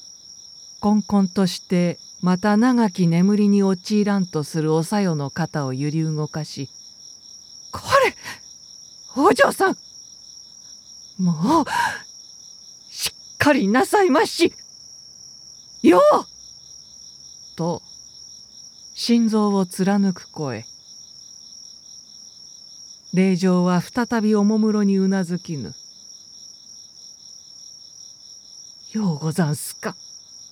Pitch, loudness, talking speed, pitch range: 190 Hz, -20 LUFS, 155 characters per minute, 165-210 Hz